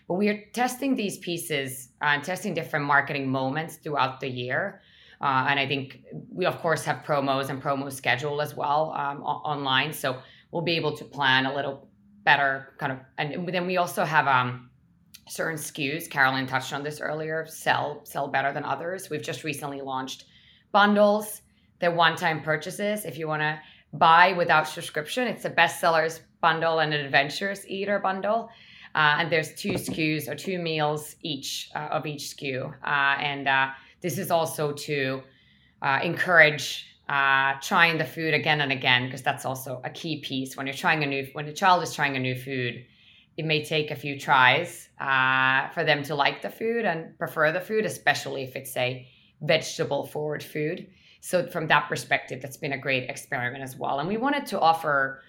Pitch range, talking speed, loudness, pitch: 135-165 Hz, 190 wpm, -25 LUFS, 150 Hz